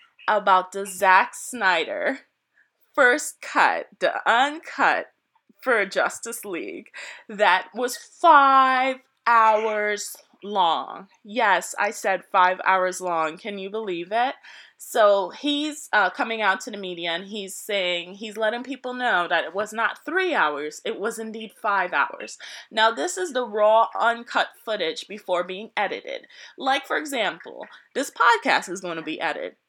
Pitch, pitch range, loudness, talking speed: 220 Hz, 190-265 Hz, -22 LUFS, 145 wpm